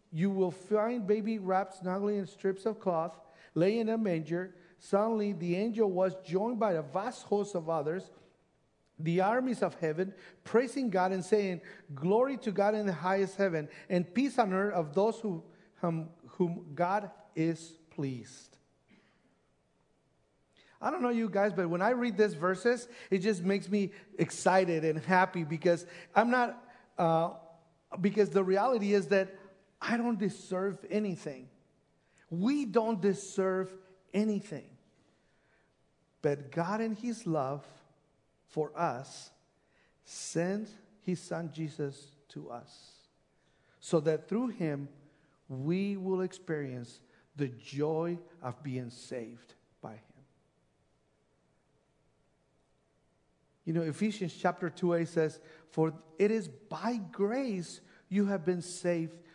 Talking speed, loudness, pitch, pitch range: 130 wpm, -33 LUFS, 185 Hz, 165-205 Hz